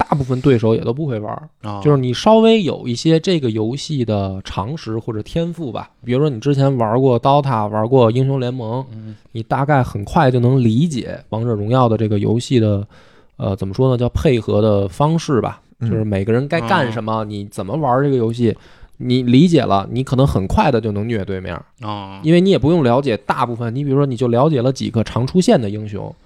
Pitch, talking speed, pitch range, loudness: 120 Hz, 320 characters per minute, 110-140 Hz, -17 LUFS